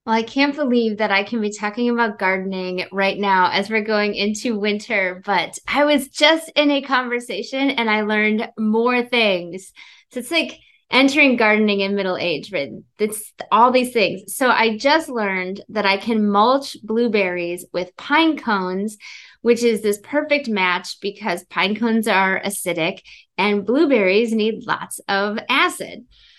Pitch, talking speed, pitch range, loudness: 215 Hz, 160 wpm, 195-245 Hz, -19 LUFS